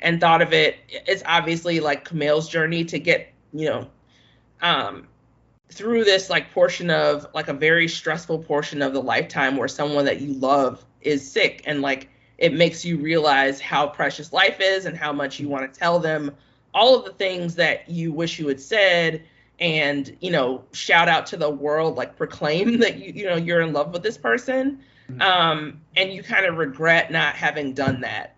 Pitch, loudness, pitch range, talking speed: 160 Hz, -21 LUFS, 145-170 Hz, 195 wpm